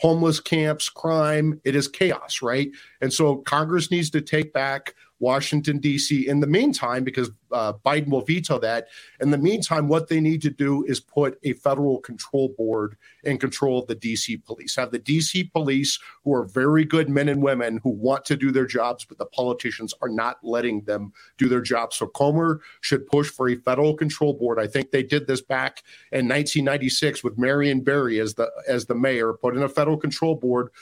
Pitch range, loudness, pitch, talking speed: 125-150 Hz, -23 LUFS, 140 Hz, 200 wpm